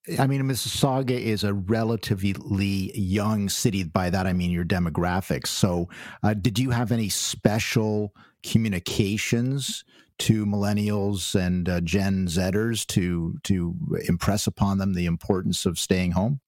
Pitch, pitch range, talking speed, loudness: 100 Hz, 95-110 Hz, 140 wpm, -25 LUFS